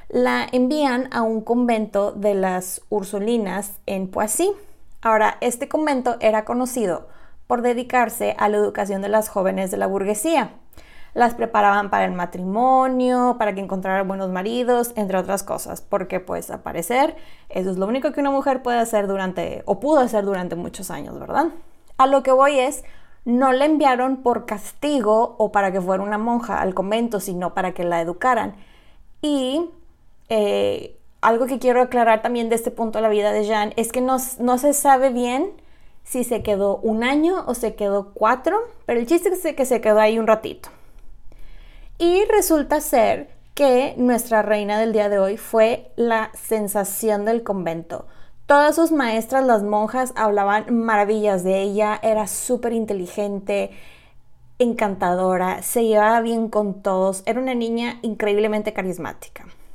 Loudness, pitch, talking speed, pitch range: -20 LUFS, 220 Hz, 165 wpm, 200-255 Hz